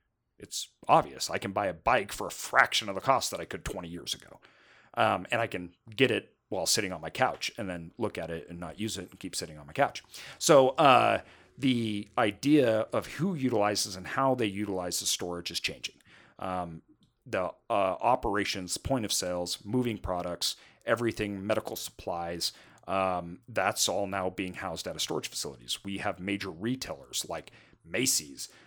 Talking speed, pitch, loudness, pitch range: 185 wpm, 100 Hz, -30 LUFS, 90-110 Hz